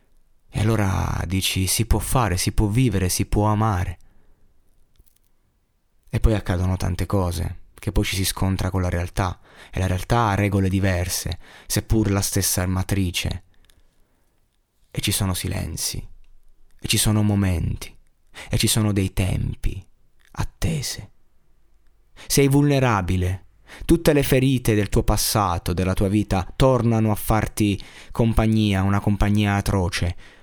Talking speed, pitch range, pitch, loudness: 130 wpm, 95-110 Hz, 100 Hz, -22 LUFS